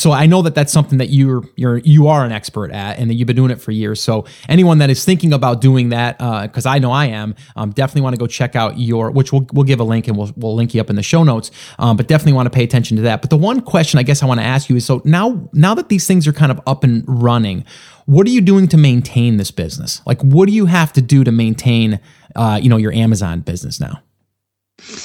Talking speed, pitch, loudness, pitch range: 280 wpm, 130 Hz, -13 LUFS, 115-150 Hz